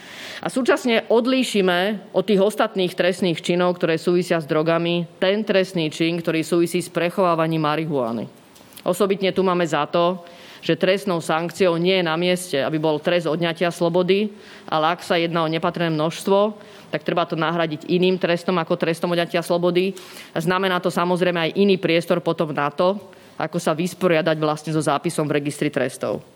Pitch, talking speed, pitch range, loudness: 175 Hz, 165 wpm, 165-185 Hz, -21 LUFS